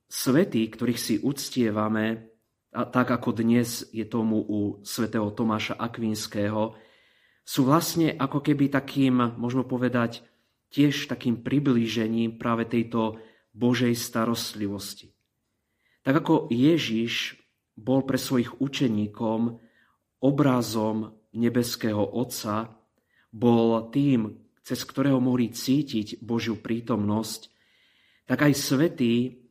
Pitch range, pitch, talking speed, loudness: 110-125 Hz, 115 Hz, 100 wpm, -26 LUFS